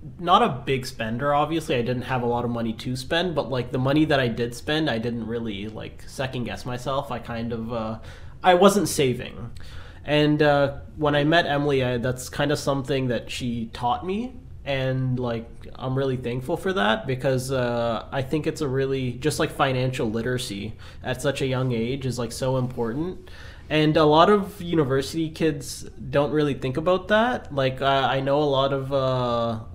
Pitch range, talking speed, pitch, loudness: 120-145 Hz, 195 wpm, 130 Hz, -24 LUFS